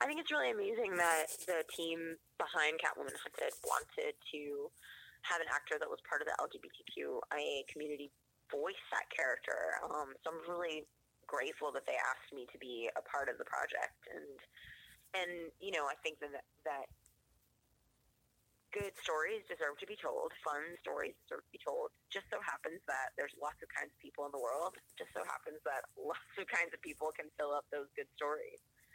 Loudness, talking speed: -41 LUFS, 185 wpm